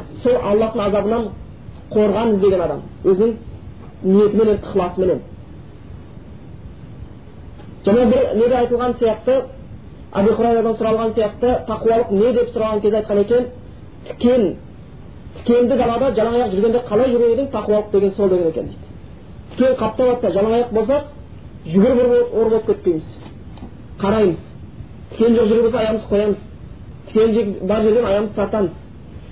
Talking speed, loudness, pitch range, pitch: 120 wpm, -17 LUFS, 205-240 Hz, 220 Hz